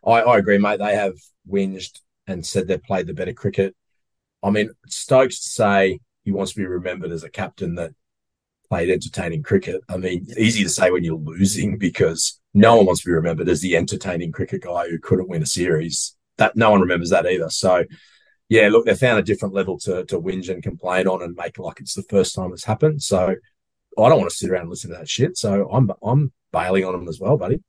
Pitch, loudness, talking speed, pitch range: 100 Hz, -20 LUFS, 230 wpm, 90-115 Hz